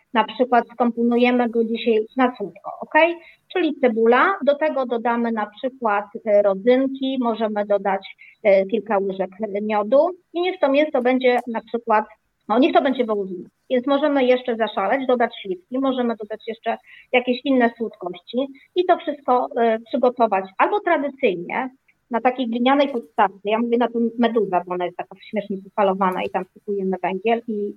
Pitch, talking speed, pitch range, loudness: 235 Hz, 150 wpm, 210-260 Hz, -21 LUFS